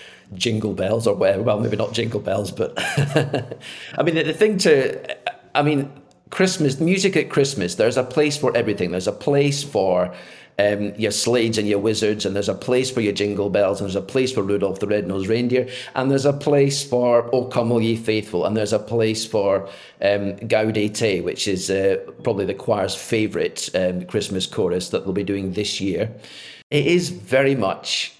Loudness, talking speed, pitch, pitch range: -21 LUFS, 190 wpm, 115 Hz, 100-140 Hz